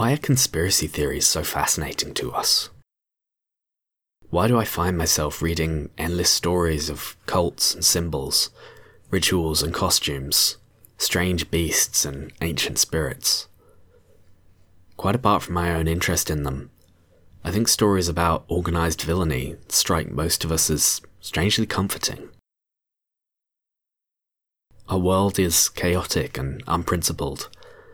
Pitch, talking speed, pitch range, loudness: 85 Hz, 120 wpm, 80-95 Hz, -22 LUFS